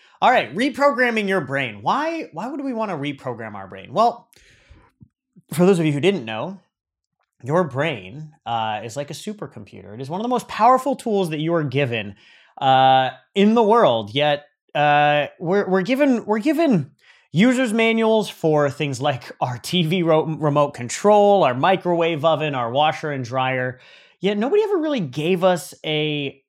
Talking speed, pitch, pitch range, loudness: 170 wpm, 165 Hz, 140-215 Hz, -20 LUFS